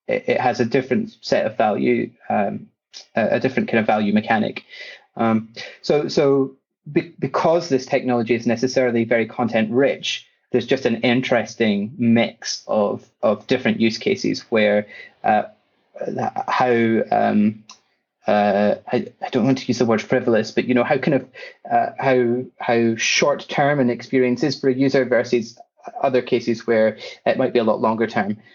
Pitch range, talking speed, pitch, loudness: 110-135 Hz, 160 wpm, 120 Hz, -20 LUFS